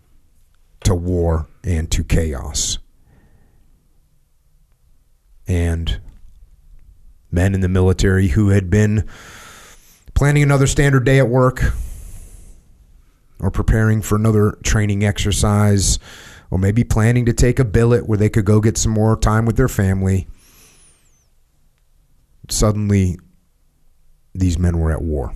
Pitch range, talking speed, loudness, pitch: 80-110 Hz, 115 wpm, -17 LUFS, 95 Hz